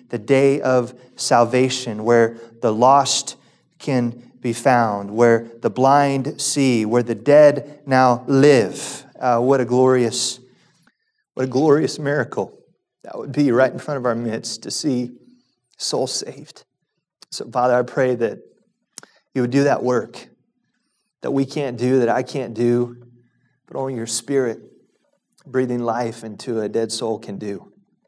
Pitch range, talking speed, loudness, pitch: 120-140 Hz, 150 wpm, -19 LUFS, 125 Hz